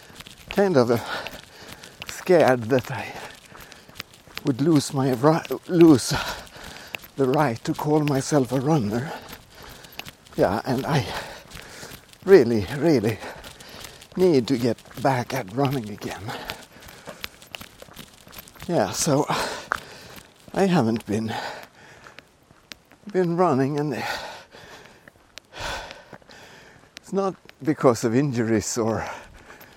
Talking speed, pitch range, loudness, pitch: 85 wpm, 120-155 Hz, -23 LUFS, 135 Hz